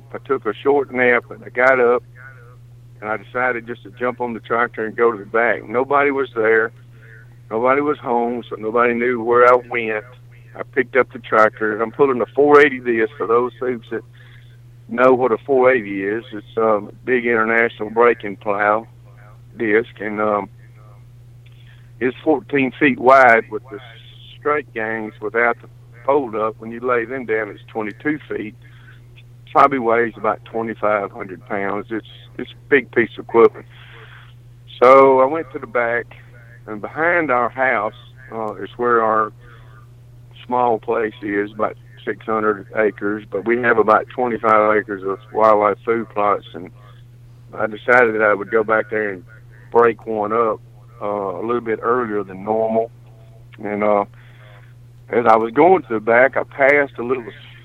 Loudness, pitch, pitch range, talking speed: -18 LUFS, 120 Hz, 110-125 Hz, 165 wpm